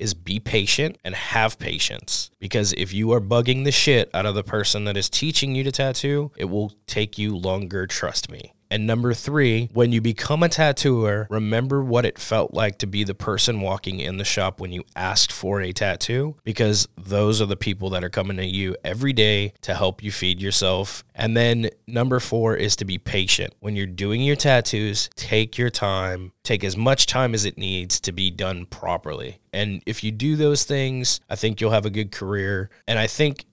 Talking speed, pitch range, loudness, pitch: 210 wpm, 100-120 Hz, -22 LUFS, 105 Hz